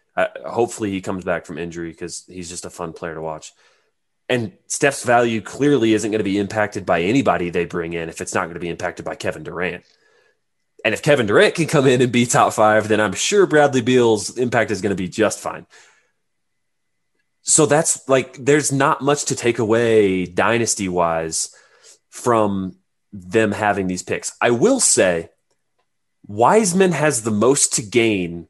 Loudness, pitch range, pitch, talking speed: -18 LUFS, 90-125 Hz, 110 Hz, 185 wpm